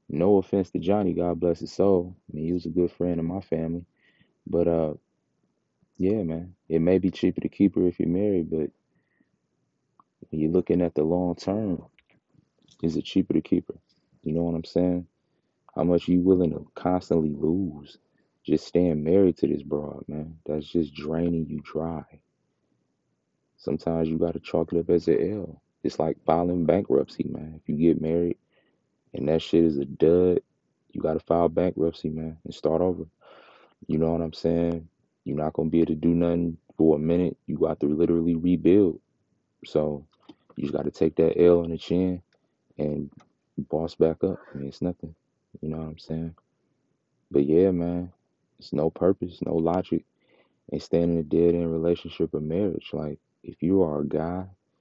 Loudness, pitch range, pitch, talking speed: -25 LUFS, 80-90 Hz, 85 Hz, 185 wpm